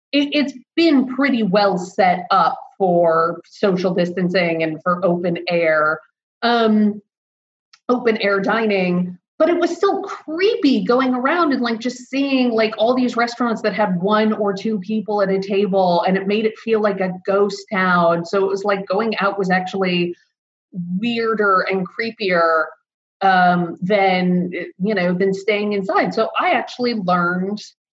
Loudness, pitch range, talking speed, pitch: -18 LUFS, 180-230 Hz, 155 wpm, 200 Hz